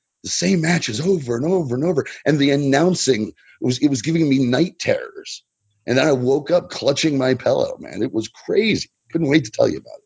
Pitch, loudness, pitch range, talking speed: 145 Hz, -19 LUFS, 130-175 Hz, 220 wpm